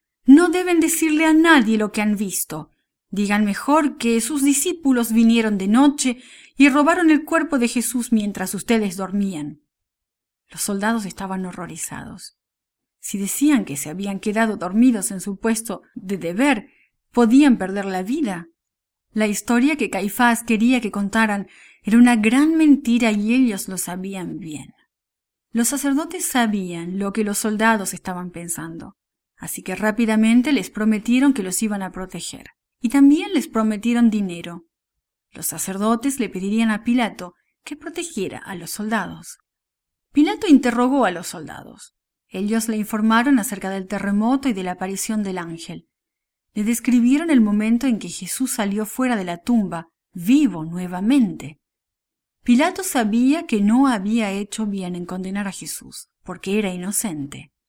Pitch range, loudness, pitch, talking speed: 195-255 Hz, -19 LUFS, 220 Hz, 150 wpm